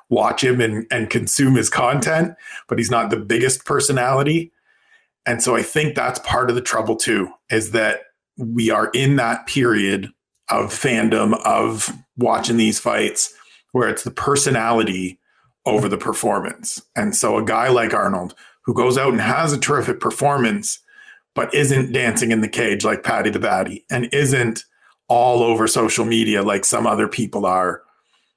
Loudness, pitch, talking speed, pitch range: -18 LUFS, 120 Hz, 165 wpm, 115-140 Hz